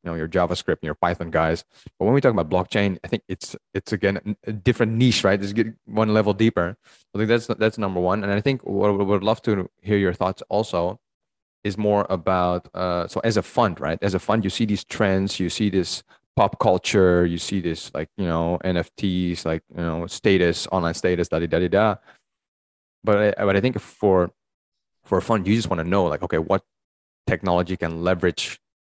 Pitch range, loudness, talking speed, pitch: 85-105 Hz, -22 LUFS, 215 wpm, 95 Hz